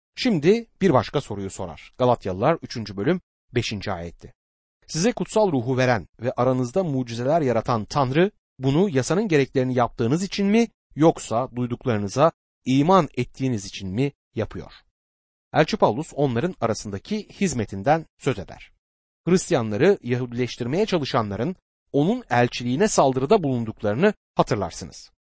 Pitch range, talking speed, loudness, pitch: 110-165 Hz, 110 wpm, -23 LUFS, 130 Hz